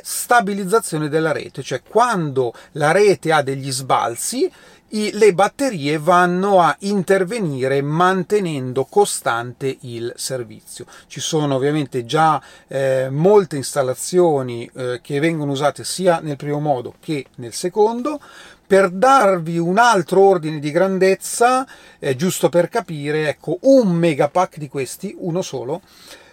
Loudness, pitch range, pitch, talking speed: -18 LUFS, 140-195 Hz, 170 Hz, 125 wpm